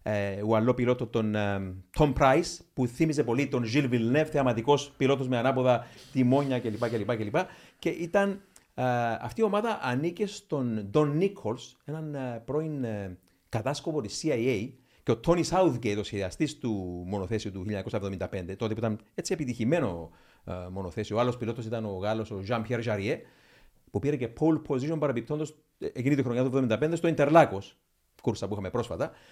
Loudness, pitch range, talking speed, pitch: -29 LUFS, 105-150 Hz, 170 wpm, 125 Hz